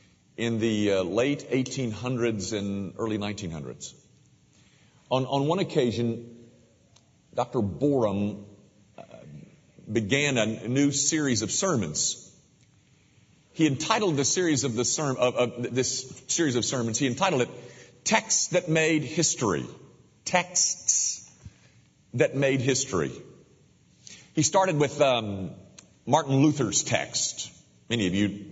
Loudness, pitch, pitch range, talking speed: -26 LUFS, 125 Hz, 110-145 Hz, 120 wpm